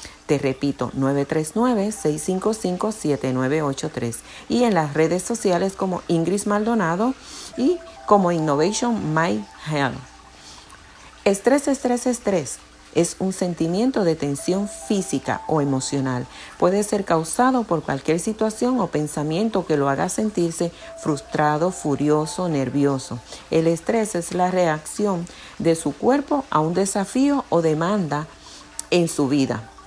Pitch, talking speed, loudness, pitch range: 170 Hz, 115 wpm, -22 LUFS, 150-210 Hz